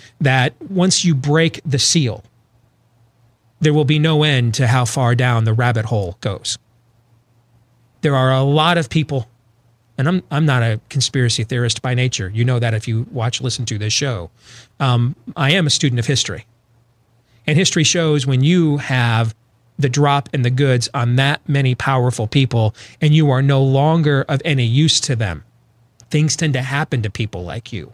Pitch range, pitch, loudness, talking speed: 115-145 Hz, 125 Hz, -17 LUFS, 185 wpm